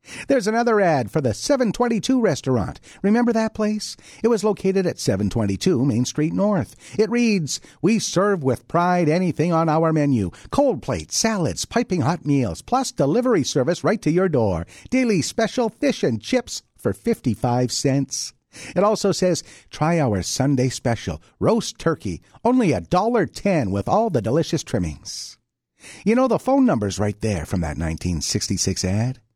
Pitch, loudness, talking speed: 160 Hz, -21 LUFS, 160 wpm